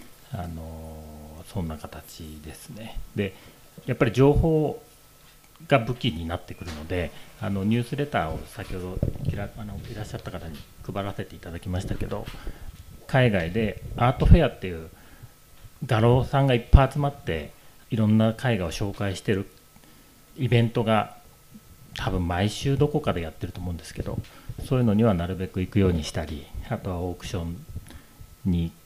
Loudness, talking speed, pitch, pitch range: -26 LUFS, 335 characters per minute, 100 Hz, 85-120 Hz